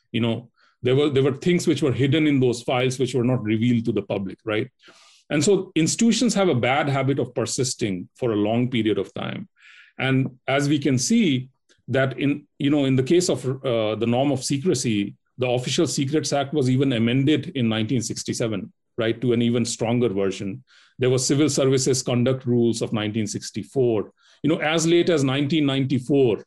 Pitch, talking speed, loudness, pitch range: 130 Hz, 190 wpm, -22 LUFS, 120-145 Hz